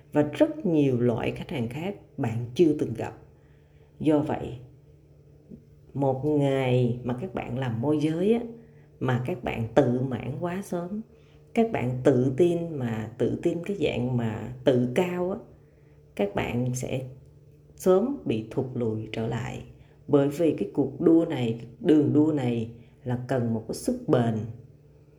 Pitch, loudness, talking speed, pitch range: 135 Hz, -26 LUFS, 155 wpm, 120-150 Hz